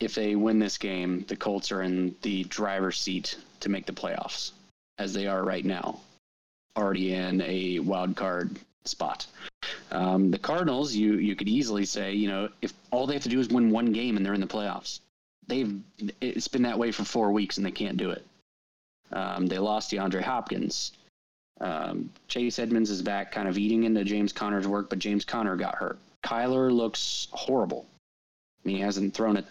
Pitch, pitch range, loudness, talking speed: 100 Hz, 95-110 Hz, -29 LUFS, 195 wpm